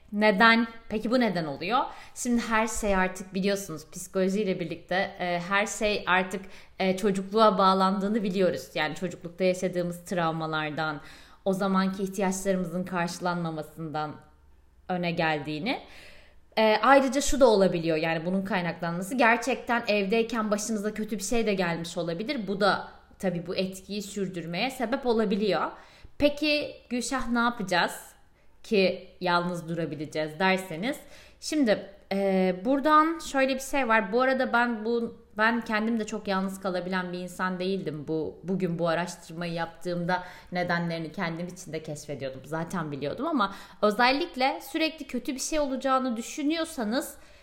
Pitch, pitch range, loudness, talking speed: 195 Hz, 175-230 Hz, -27 LUFS, 130 wpm